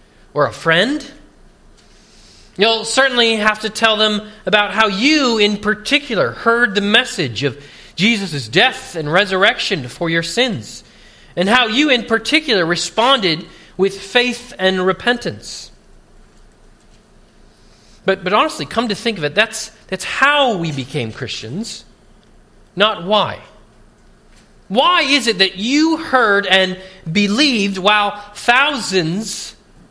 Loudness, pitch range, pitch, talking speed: -15 LUFS, 180-235 Hz, 210 Hz, 120 wpm